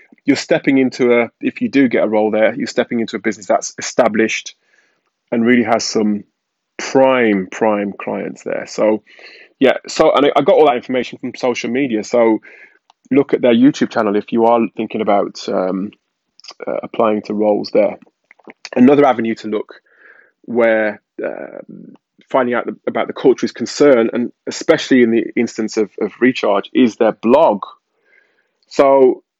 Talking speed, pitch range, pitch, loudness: 165 wpm, 110-130 Hz, 115 Hz, -15 LUFS